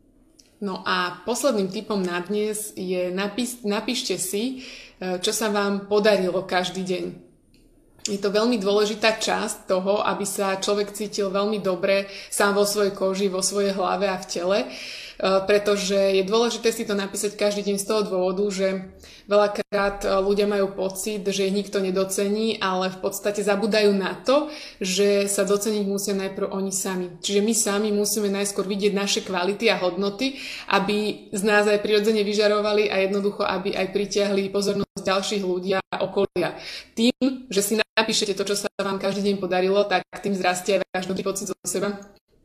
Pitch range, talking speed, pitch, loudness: 195-210 Hz, 165 wpm, 200 Hz, -23 LUFS